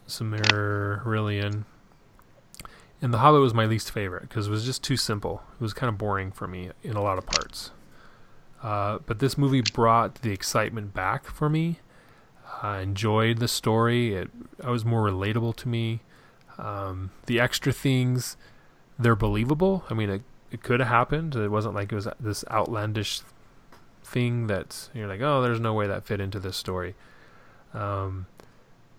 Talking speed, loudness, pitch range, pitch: 170 wpm, -26 LUFS, 100-120 Hz, 110 Hz